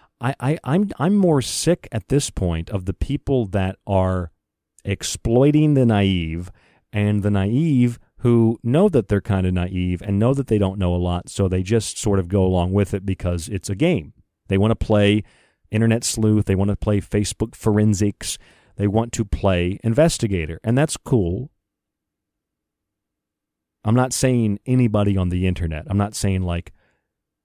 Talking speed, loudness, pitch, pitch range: 175 wpm, -20 LUFS, 105 Hz, 95-115 Hz